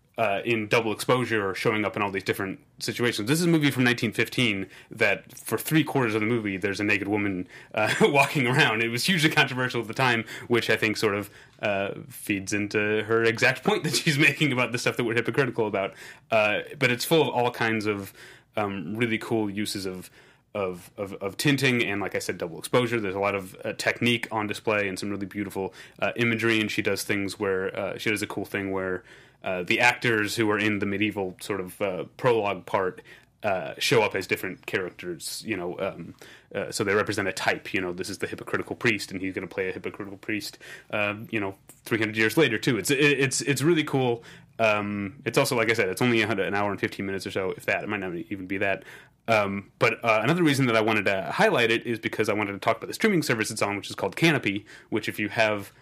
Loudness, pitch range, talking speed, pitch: -25 LUFS, 100-125 Hz, 235 wpm, 110 Hz